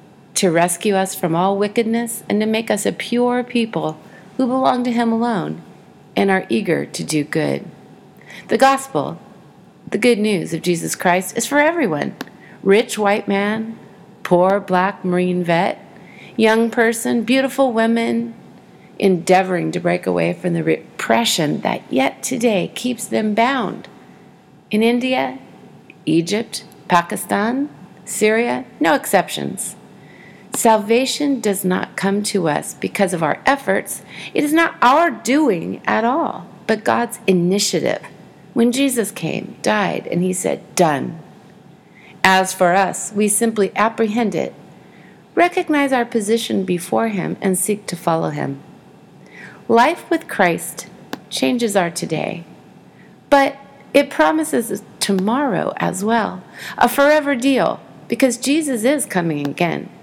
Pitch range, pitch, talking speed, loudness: 185-240 Hz, 205 Hz, 130 wpm, -18 LUFS